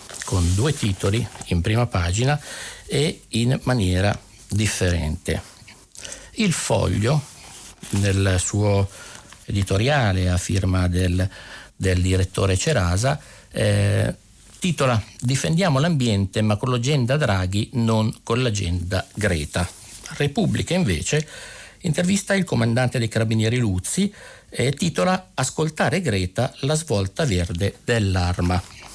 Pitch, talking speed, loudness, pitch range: 110 Hz, 105 wpm, -22 LUFS, 95-130 Hz